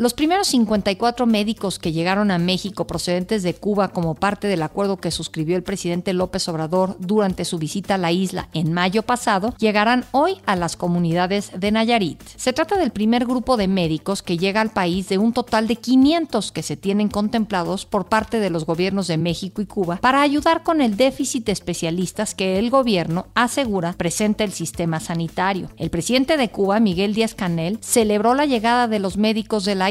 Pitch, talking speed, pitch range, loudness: 200 Hz, 190 wpm, 180-230 Hz, -20 LUFS